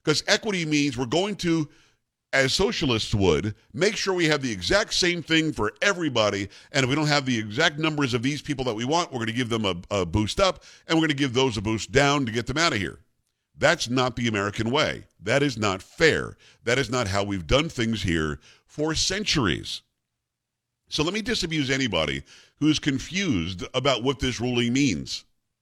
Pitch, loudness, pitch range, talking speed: 135 Hz, -24 LUFS, 115-160 Hz, 210 wpm